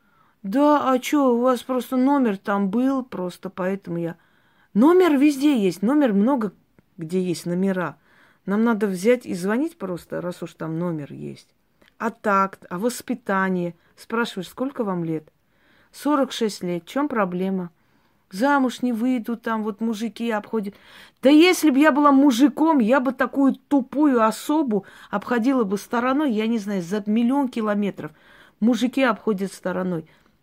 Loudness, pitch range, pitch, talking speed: -22 LUFS, 185-260 Hz, 225 Hz, 145 wpm